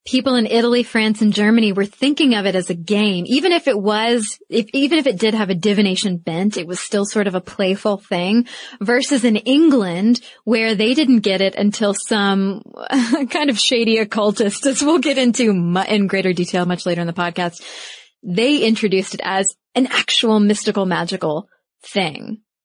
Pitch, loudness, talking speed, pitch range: 215 Hz, -17 LUFS, 185 wpm, 195-245 Hz